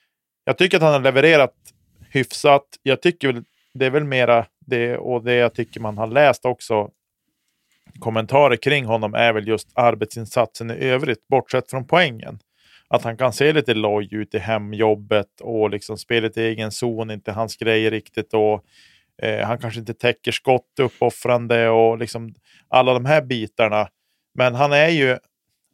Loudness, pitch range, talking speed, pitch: -19 LUFS, 110-130 Hz, 170 wpm, 115 Hz